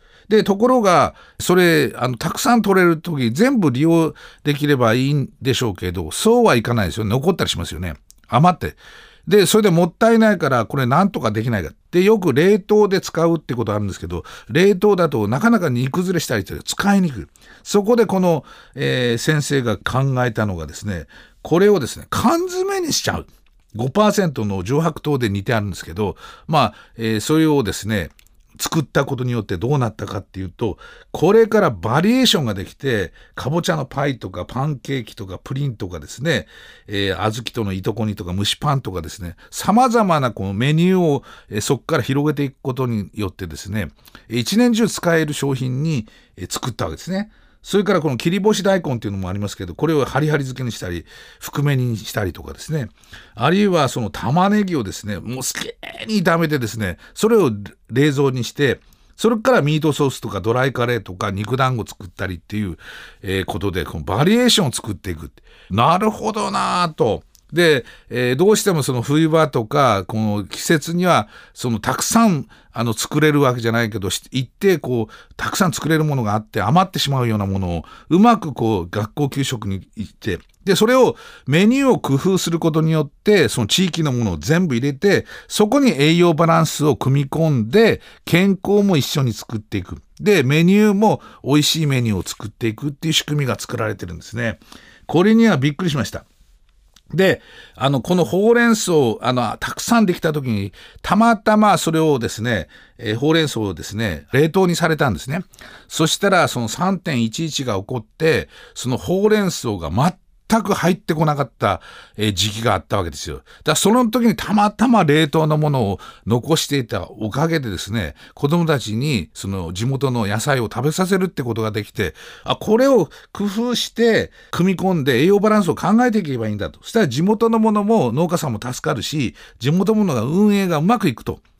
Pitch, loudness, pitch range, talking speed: 140 Hz, -18 LUFS, 110-180 Hz, 385 characters per minute